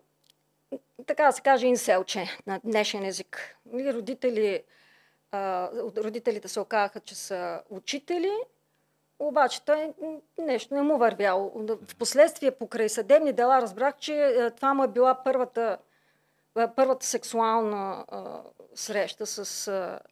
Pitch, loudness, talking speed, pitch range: 240 Hz, -27 LUFS, 110 wpm, 210-275 Hz